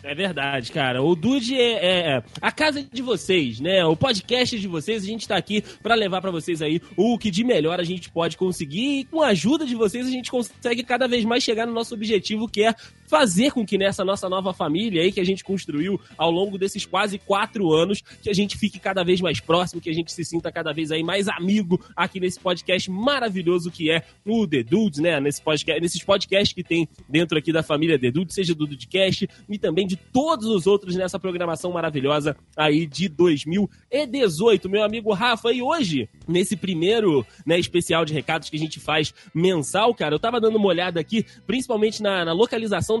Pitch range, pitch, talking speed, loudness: 165-220 Hz, 190 Hz, 210 wpm, -22 LUFS